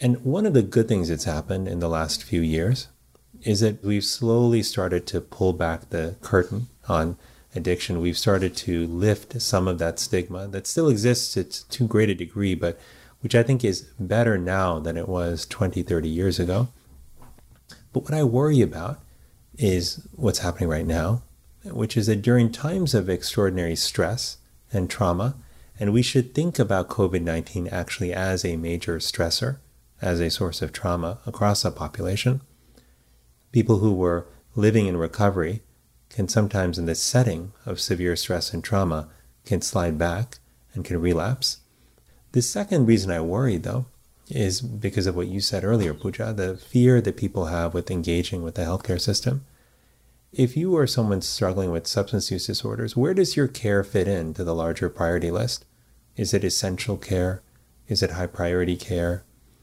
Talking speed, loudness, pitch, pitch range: 170 wpm, -24 LUFS, 95 Hz, 85-115 Hz